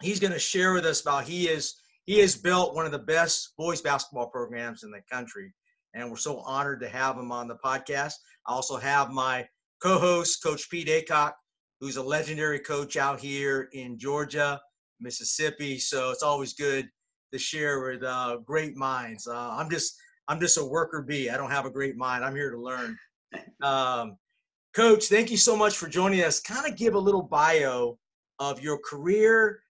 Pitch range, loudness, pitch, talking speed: 130-175 Hz, -27 LUFS, 145 Hz, 190 wpm